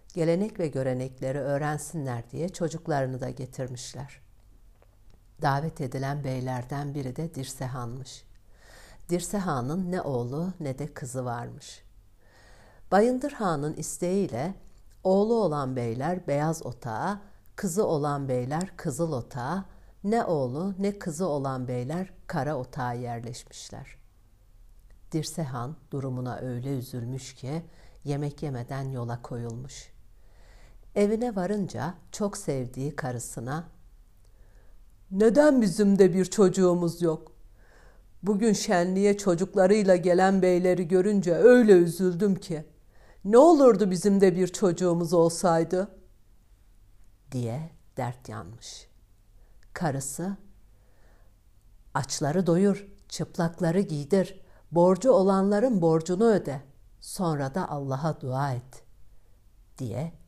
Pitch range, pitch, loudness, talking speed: 120-180 Hz, 145 Hz, -26 LUFS, 95 wpm